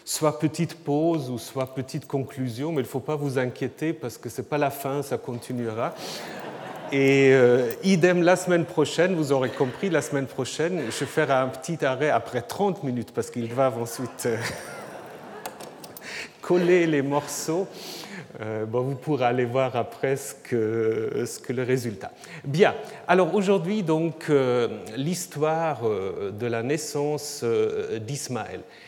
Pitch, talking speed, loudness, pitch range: 140 Hz, 155 wpm, -25 LUFS, 125-160 Hz